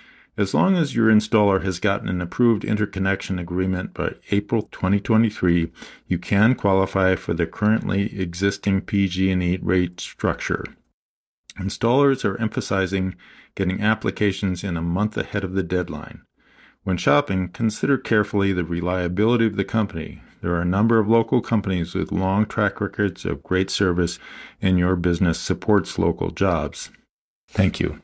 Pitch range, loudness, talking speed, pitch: 90-105 Hz, -22 LUFS, 145 wpm, 95 Hz